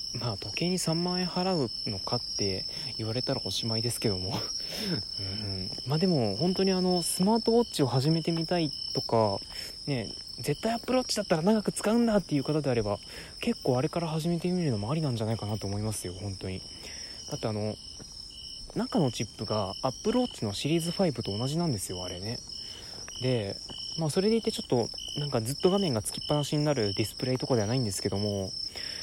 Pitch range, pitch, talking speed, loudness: 105-170 Hz, 130 Hz, 410 characters per minute, -30 LUFS